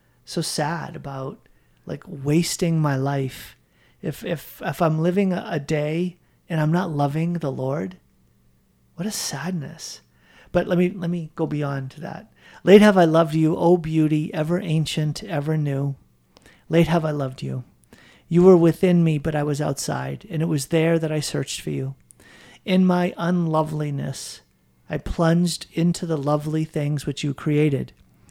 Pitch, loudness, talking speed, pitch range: 155 Hz, -22 LUFS, 165 wpm, 140-170 Hz